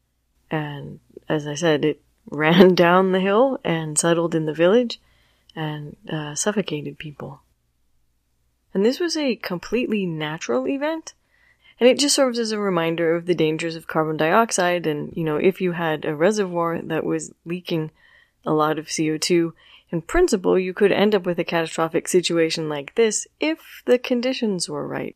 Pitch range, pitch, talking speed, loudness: 155-205 Hz, 170 Hz, 165 wpm, -21 LUFS